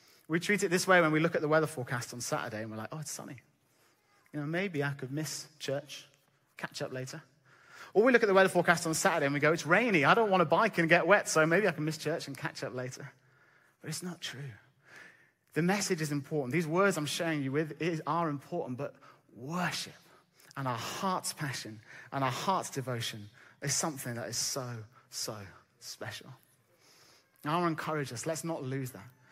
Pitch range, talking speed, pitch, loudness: 130-170 Hz, 210 wpm, 150 Hz, -31 LUFS